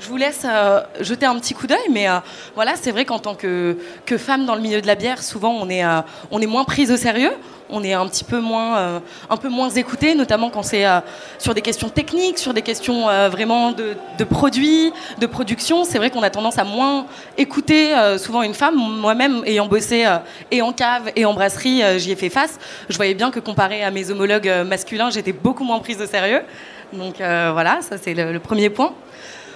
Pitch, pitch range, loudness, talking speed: 225 Hz, 200-255 Hz, -18 LUFS, 235 wpm